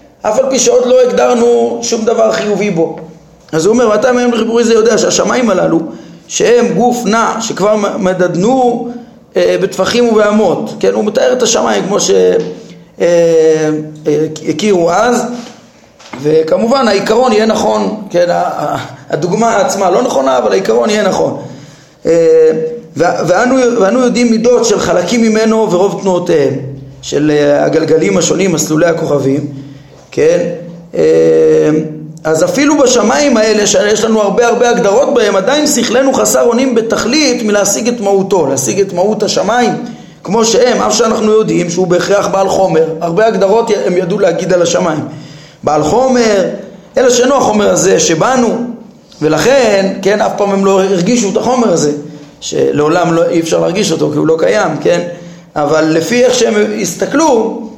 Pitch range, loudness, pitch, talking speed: 170-240 Hz, -10 LUFS, 210 Hz, 145 wpm